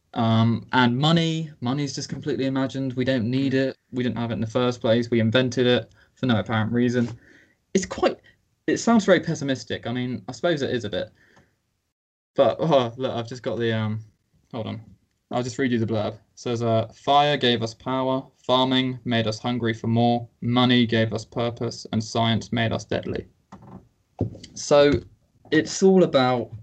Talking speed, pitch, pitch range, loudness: 185 wpm, 120 Hz, 110-130 Hz, -23 LUFS